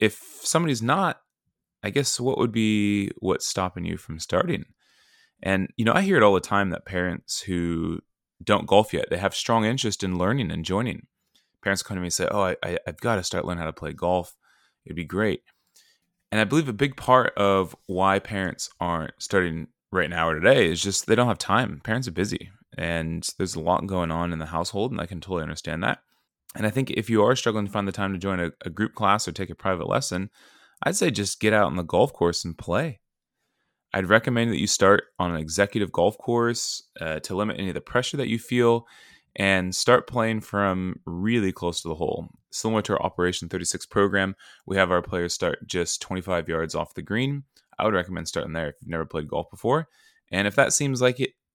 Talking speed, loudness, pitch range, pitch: 225 wpm, -25 LUFS, 85-110 Hz, 95 Hz